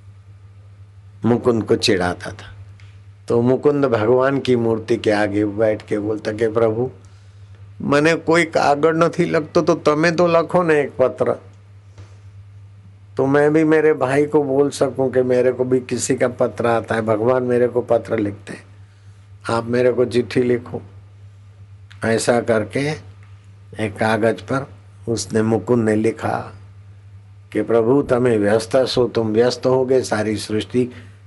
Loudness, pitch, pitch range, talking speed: -18 LUFS, 115 Hz, 100-130 Hz, 145 wpm